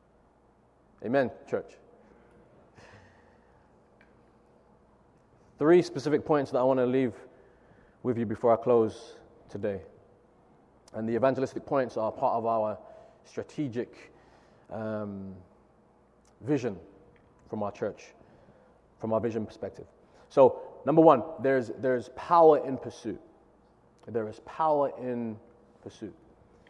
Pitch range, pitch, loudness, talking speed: 110-145 Hz, 125 Hz, -28 LUFS, 105 wpm